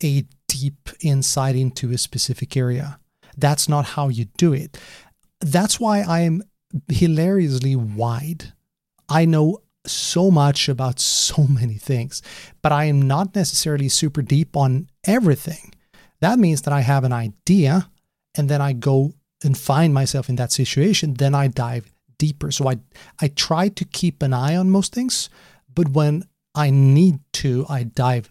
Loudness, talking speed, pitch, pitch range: -19 LUFS, 160 wpm, 145 Hz, 135-165 Hz